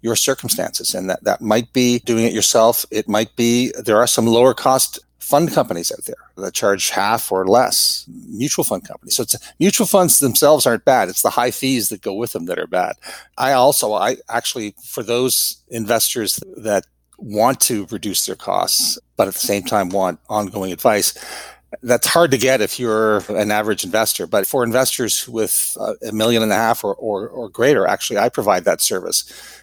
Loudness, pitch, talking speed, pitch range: -17 LUFS, 115 Hz, 195 wpm, 110-130 Hz